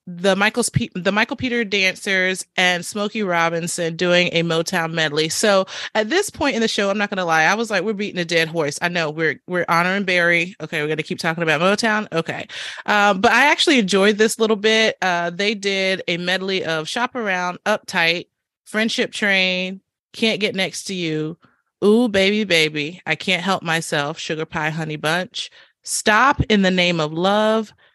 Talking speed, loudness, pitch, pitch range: 195 wpm, -19 LUFS, 185 Hz, 165-210 Hz